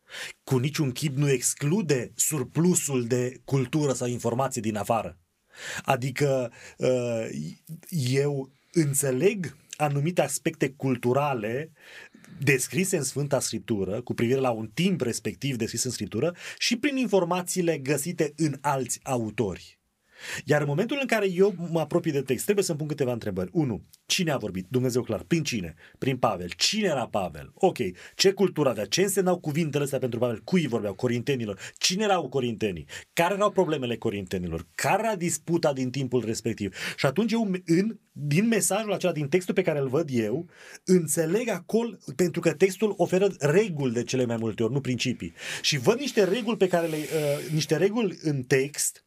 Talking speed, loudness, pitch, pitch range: 160 wpm, -26 LUFS, 145 Hz, 125-180 Hz